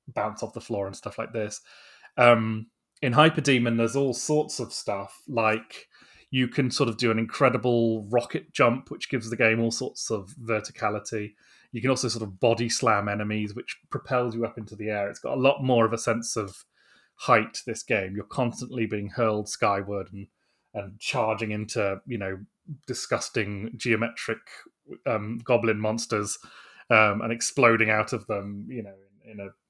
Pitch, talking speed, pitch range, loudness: 115 Hz, 180 wpm, 105-125 Hz, -26 LUFS